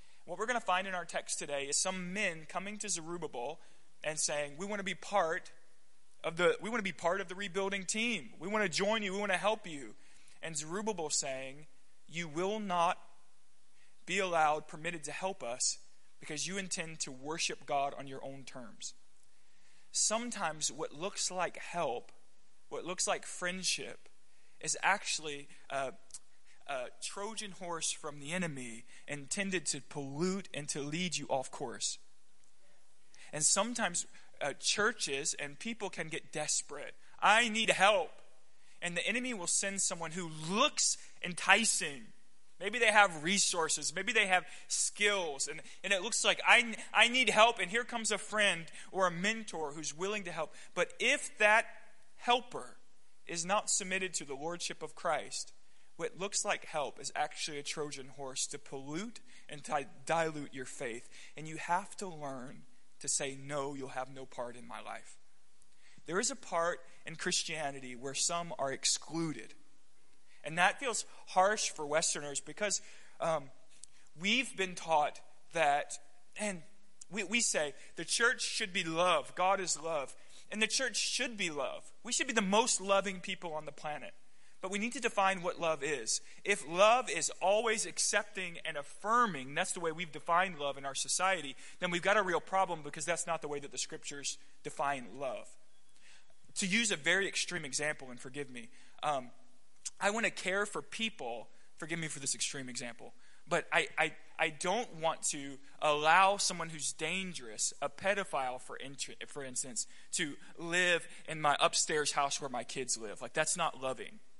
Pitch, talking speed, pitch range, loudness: 175 Hz, 175 wpm, 150-200 Hz, -34 LUFS